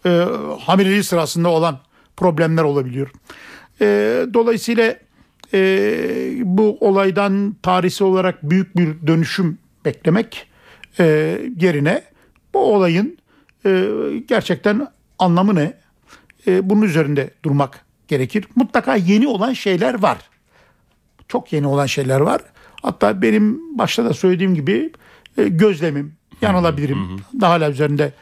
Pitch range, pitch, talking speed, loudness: 155-210 Hz, 185 Hz, 110 wpm, -17 LUFS